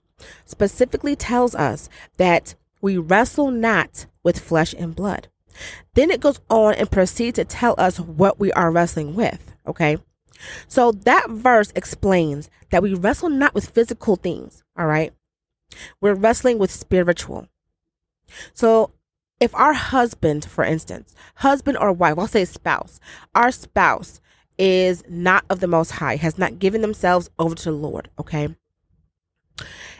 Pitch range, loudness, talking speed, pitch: 165-225 Hz, -19 LUFS, 145 wpm, 185 Hz